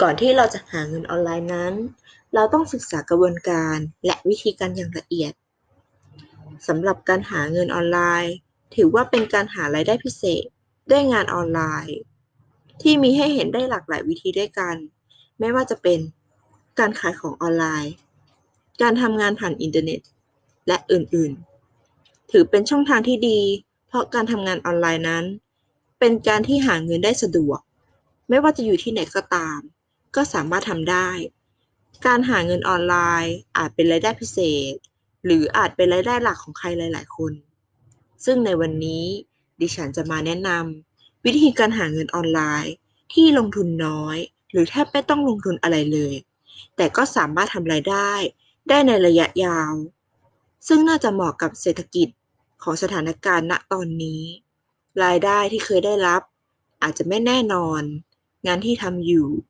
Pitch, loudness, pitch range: 175 Hz, -20 LUFS, 155-220 Hz